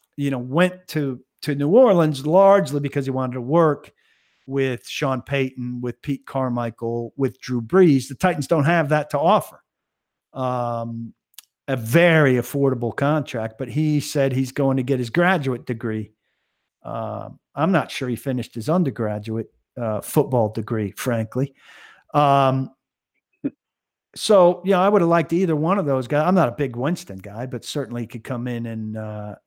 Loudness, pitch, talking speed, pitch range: -21 LUFS, 135 Hz, 170 wpm, 120-150 Hz